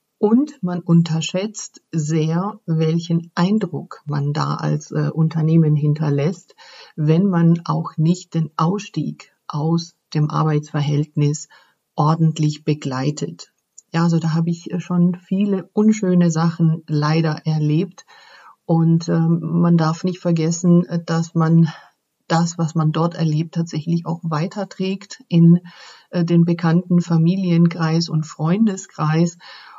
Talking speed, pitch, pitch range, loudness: 115 wpm, 165 Hz, 160-175 Hz, -19 LUFS